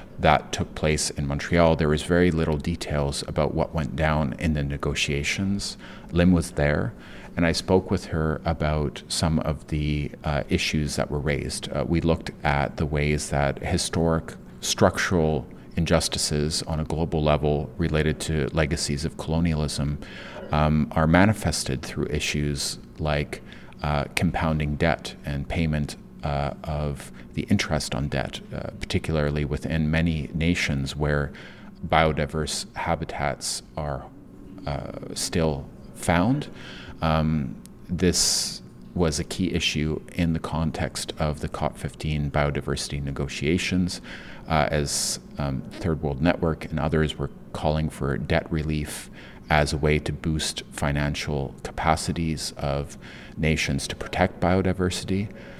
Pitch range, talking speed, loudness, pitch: 70-80 Hz, 130 wpm, -25 LUFS, 75 Hz